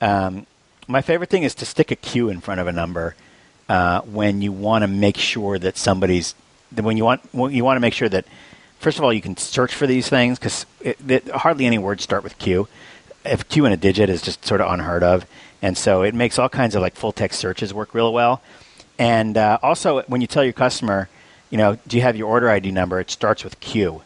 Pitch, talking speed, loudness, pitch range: 110 Hz, 235 wpm, -19 LUFS, 95-125 Hz